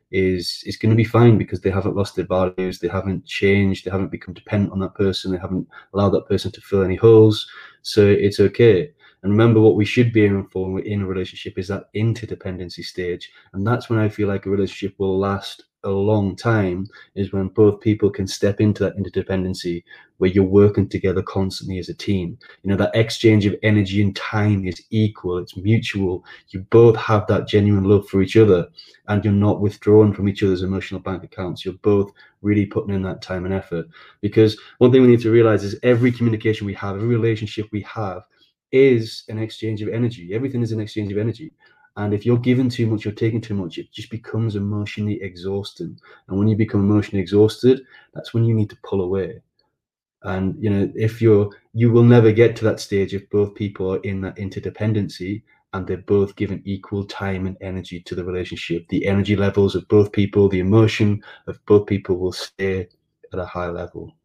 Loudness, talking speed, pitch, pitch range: -19 LUFS, 205 wpm, 100 Hz, 95-110 Hz